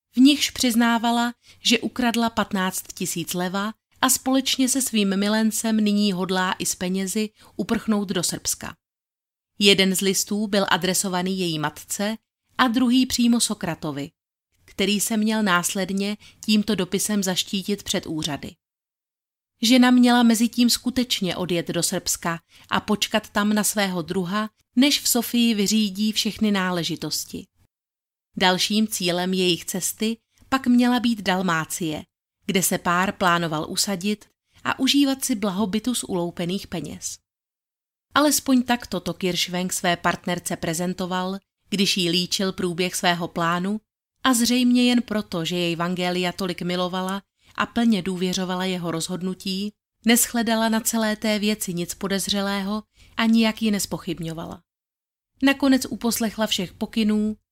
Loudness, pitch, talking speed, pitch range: -22 LUFS, 200 Hz, 130 wpm, 180-225 Hz